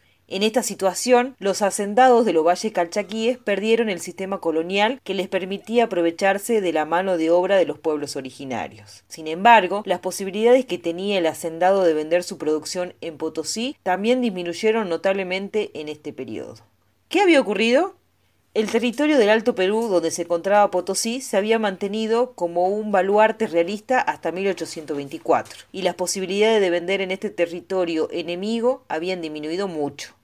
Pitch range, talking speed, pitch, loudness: 170-220 Hz, 155 wpm, 190 Hz, -21 LUFS